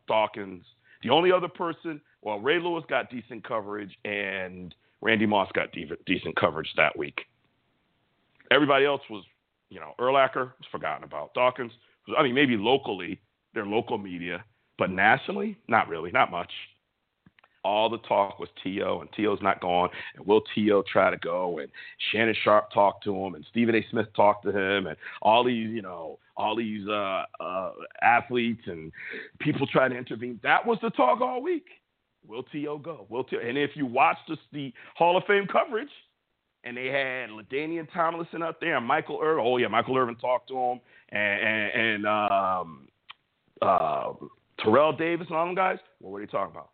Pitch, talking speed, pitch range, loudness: 125 Hz, 180 wpm, 105-155 Hz, -26 LUFS